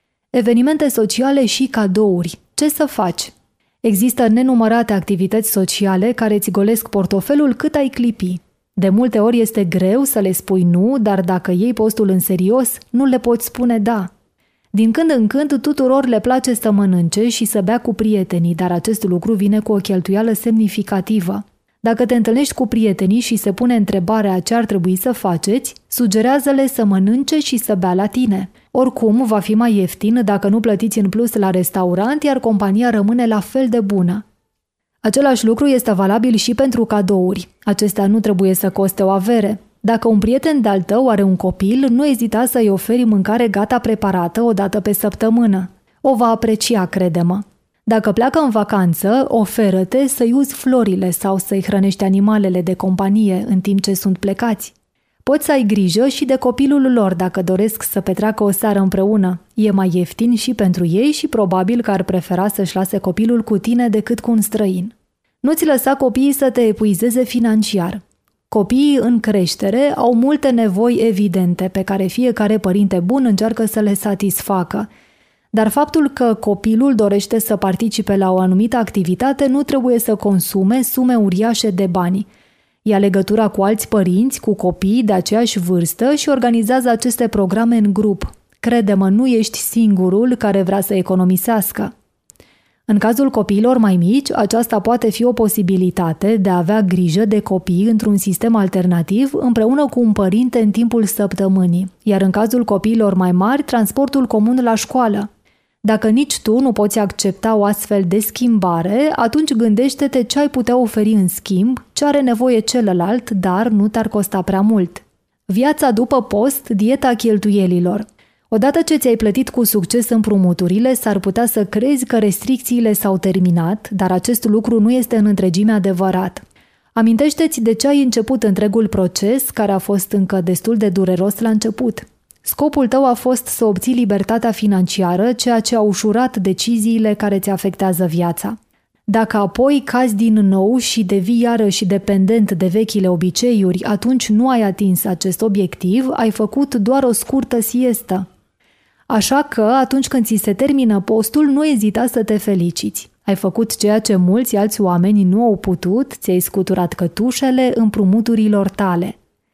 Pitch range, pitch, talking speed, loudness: 195-240 Hz, 215 Hz, 165 wpm, -15 LUFS